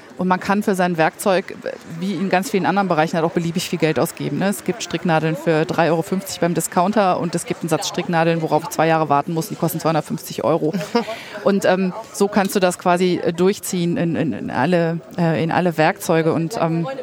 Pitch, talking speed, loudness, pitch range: 170 Hz, 210 wpm, -19 LUFS, 165-185 Hz